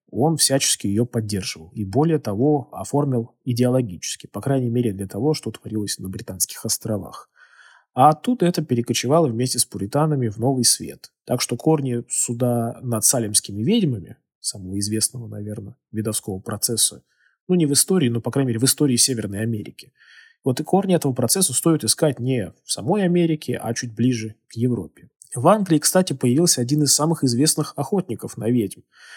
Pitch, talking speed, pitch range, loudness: 125 Hz, 165 wpm, 110-150 Hz, -21 LUFS